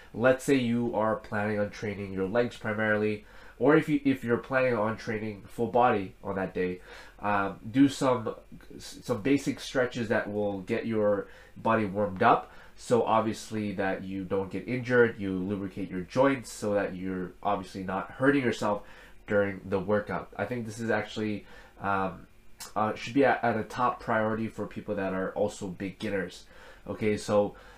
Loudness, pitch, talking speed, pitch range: -29 LUFS, 105 Hz, 170 wpm, 100-120 Hz